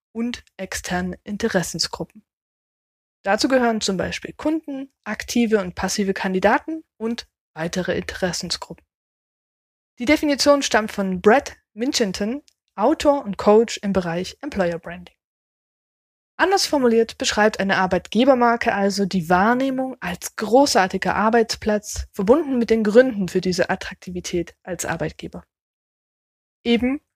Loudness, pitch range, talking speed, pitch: -20 LUFS, 185-250 Hz, 110 wpm, 215 Hz